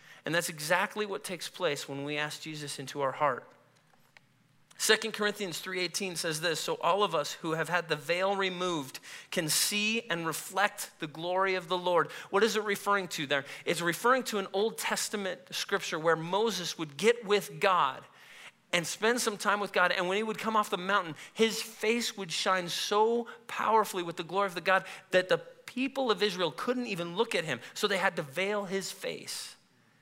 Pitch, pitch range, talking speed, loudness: 190 Hz, 170-210 Hz, 200 wpm, -30 LUFS